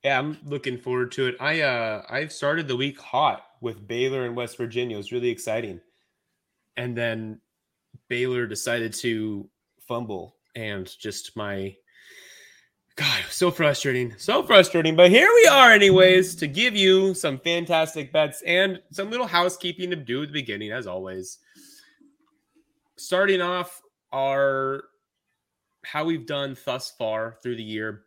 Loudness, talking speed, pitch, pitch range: -22 LUFS, 150 wpm, 140 Hz, 120-180 Hz